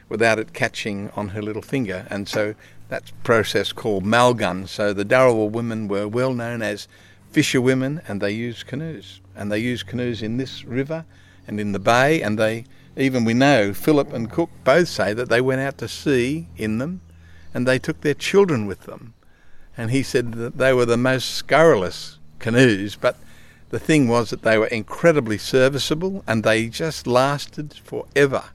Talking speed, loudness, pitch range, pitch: 180 wpm, -20 LUFS, 105-130 Hz, 115 Hz